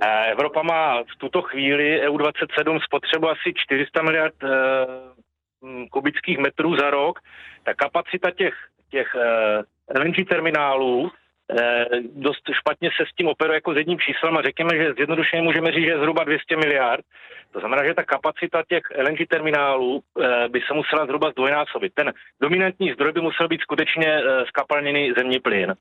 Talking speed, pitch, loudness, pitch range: 165 wpm, 150 Hz, -21 LUFS, 135-165 Hz